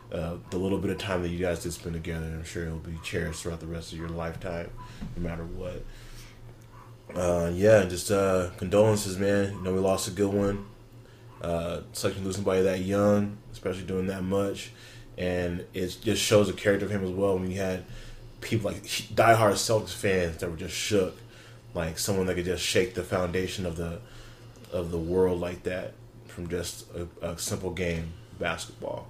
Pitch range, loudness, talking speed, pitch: 90-110 Hz, -28 LUFS, 200 wpm, 95 Hz